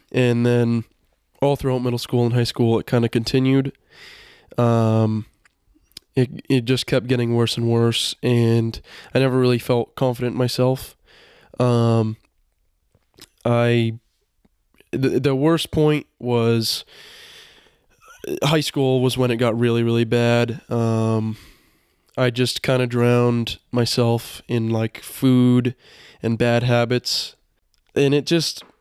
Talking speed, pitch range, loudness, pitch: 130 wpm, 115-130 Hz, -20 LUFS, 120 Hz